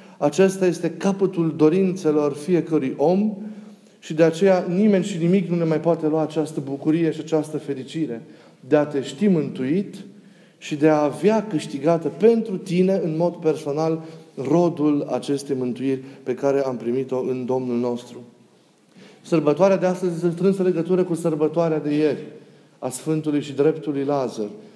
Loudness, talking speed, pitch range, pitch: -21 LUFS, 150 wpm, 145-185 Hz, 160 Hz